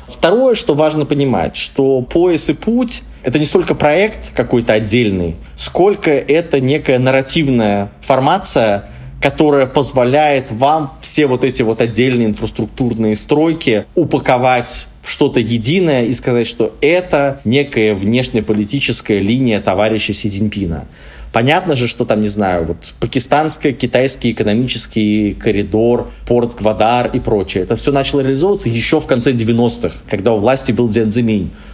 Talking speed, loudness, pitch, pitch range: 130 wpm, -14 LUFS, 125 Hz, 110-140 Hz